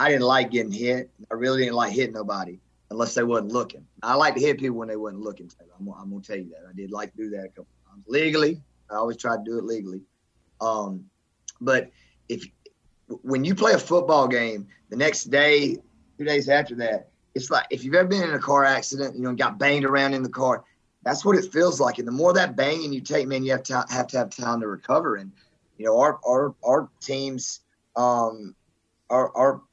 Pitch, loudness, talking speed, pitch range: 125 Hz, -23 LUFS, 235 wpm, 110-140 Hz